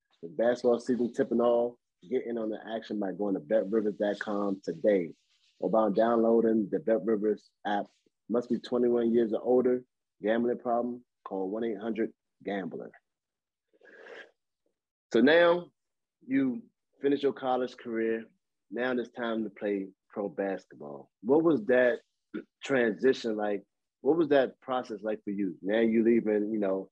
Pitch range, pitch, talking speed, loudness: 105-125 Hz, 115 Hz, 145 wpm, -29 LUFS